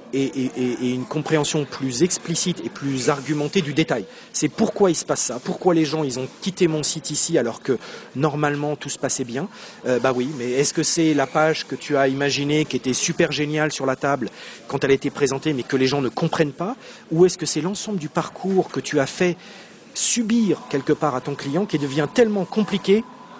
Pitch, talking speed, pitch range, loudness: 155 Hz, 225 wpm, 140-180 Hz, -21 LUFS